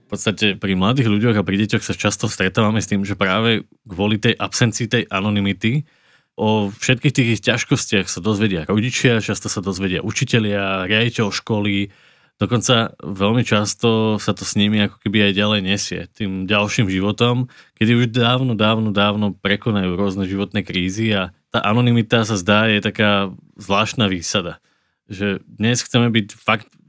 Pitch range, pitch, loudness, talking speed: 100-115 Hz, 105 Hz, -18 LUFS, 160 wpm